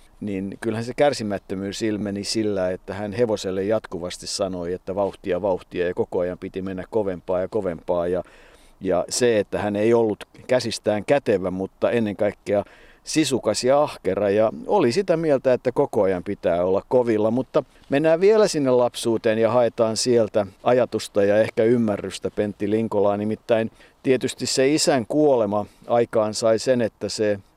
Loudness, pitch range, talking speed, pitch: -22 LUFS, 100-125 Hz, 155 wpm, 110 Hz